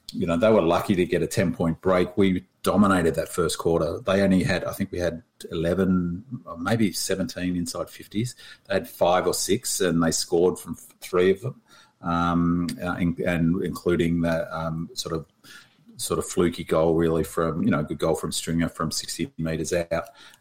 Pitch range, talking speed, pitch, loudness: 85-90 Hz, 190 wpm, 85 Hz, -24 LUFS